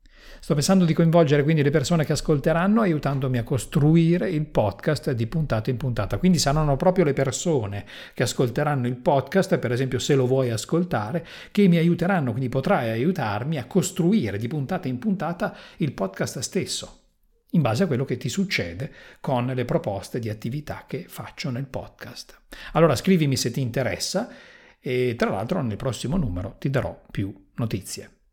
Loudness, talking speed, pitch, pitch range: -23 LUFS, 165 wpm, 140 Hz, 125-170 Hz